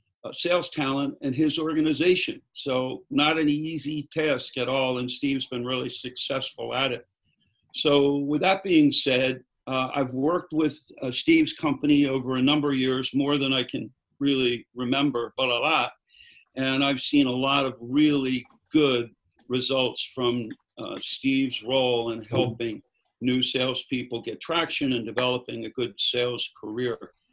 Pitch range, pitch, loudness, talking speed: 125-150 Hz, 135 Hz, -25 LUFS, 155 wpm